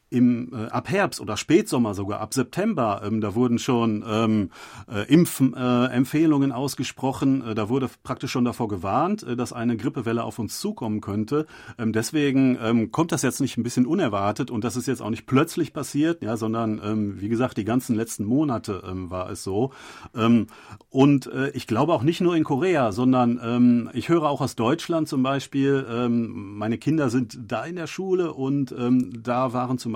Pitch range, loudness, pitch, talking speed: 115-140 Hz, -24 LUFS, 125 Hz, 190 wpm